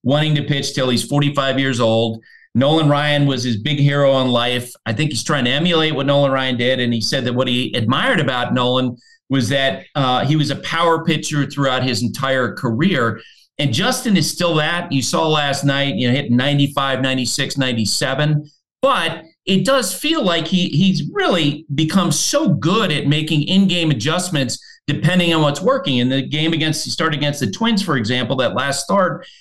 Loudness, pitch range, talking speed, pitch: -17 LUFS, 130-165 Hz, 195 wpm, 145 Hz